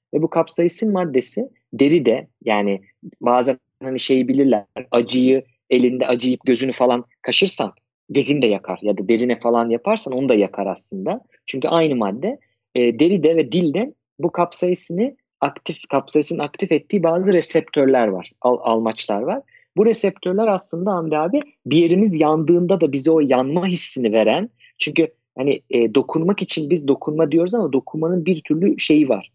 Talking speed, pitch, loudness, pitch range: 155 wpm, 150 Hz, -19 LUFS, 125-175 Hz